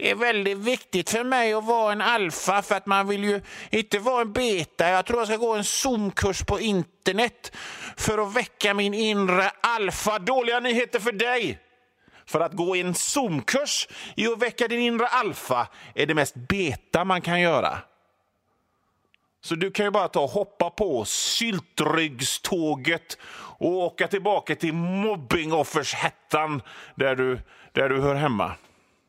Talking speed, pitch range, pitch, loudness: 160 wpm, 165-230 Hz, 200 Hz, -24 LUFS